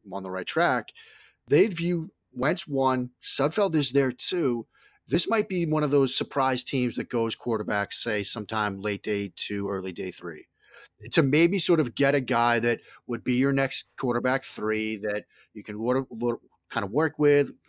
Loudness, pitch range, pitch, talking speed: -26 LUFS, 105-145 Hz, 125 Hz, 175 wpm